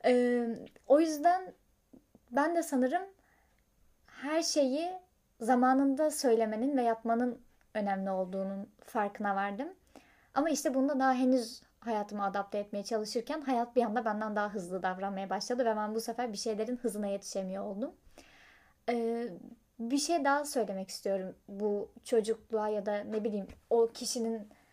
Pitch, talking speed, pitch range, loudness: 230 Hz, 135 wpm, 210-260 Hz, -33 LUFS